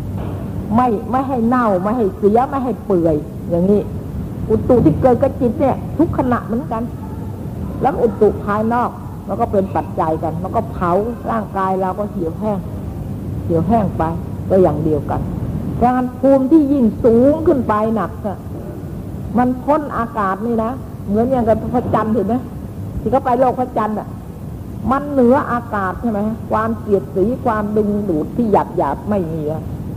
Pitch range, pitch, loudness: 195-245 Hz, 220 Hz, -17 LUFS